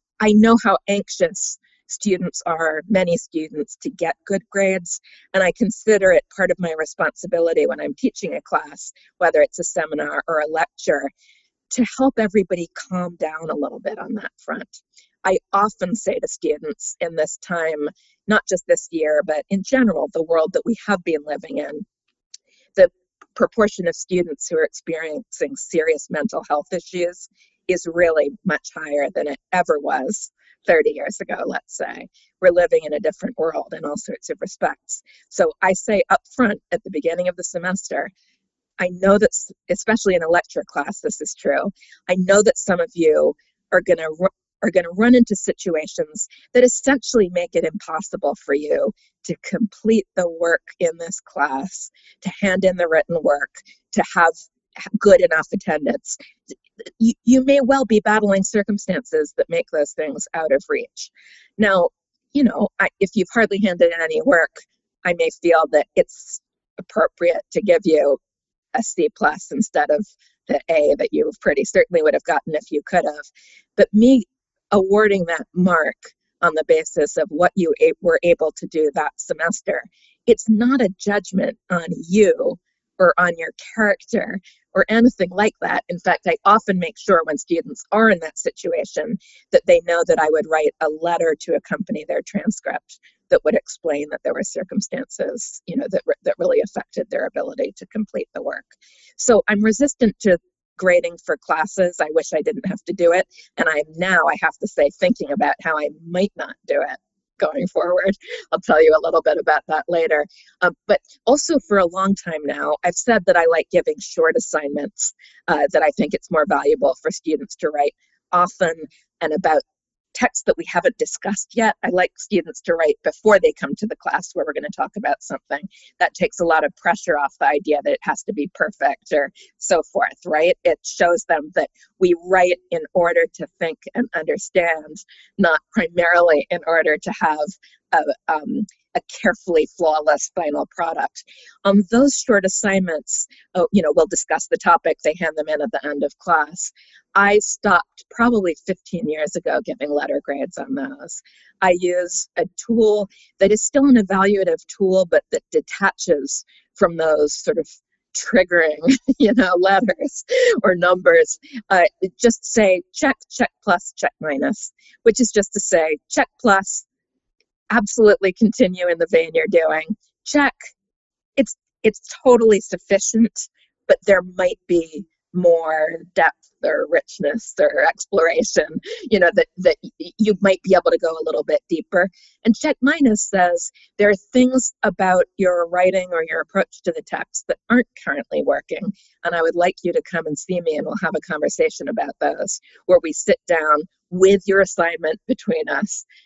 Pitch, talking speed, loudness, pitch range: 205 Hz, 180 wpm, -19 LUFS, 175-265 Hz